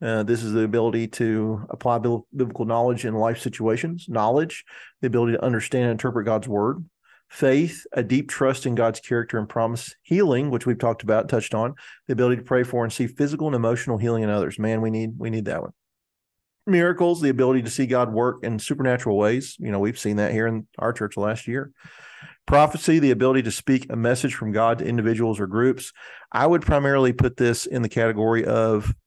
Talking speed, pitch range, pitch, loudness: 210 wpm, 110-130 Hz, 120 Hz, -23 LUFS